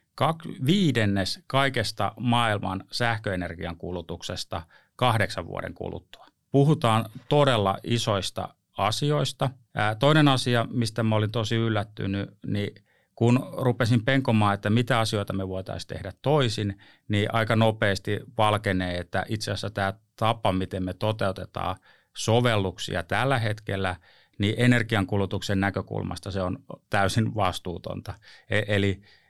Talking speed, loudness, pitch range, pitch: 115 wpm, -26 LUFS, 95-120 Hz, 105 Hz